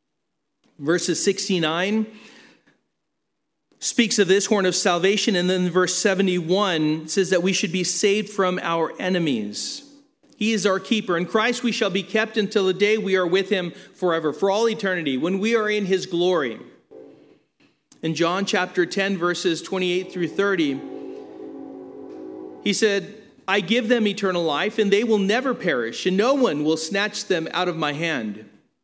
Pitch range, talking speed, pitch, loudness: 180-220 Hz, 160 wpm, 195 Hz, -22 LUFS